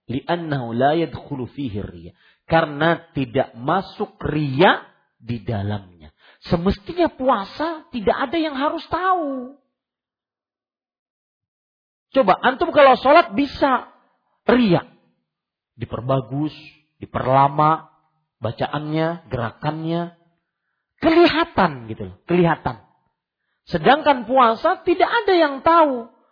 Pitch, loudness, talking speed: 170 Hz, -19 LUFS, 75 wpm